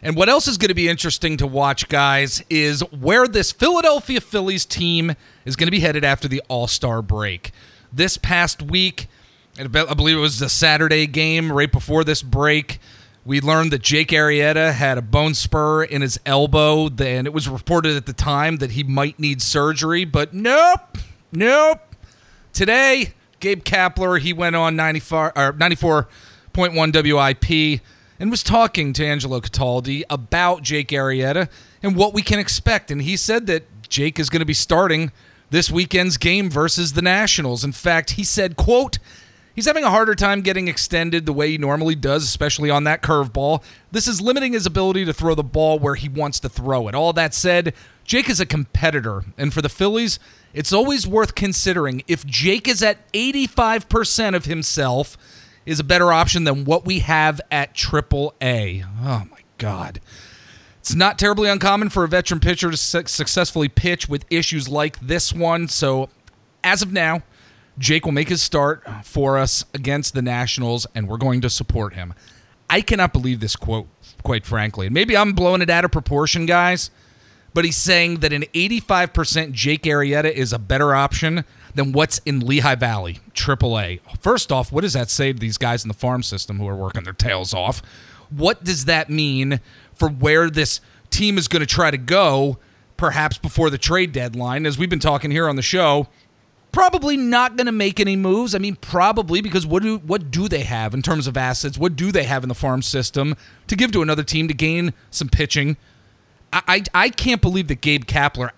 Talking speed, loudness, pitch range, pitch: 190 wpm, -18 LUFS, 130-175 Hz, 150 Hz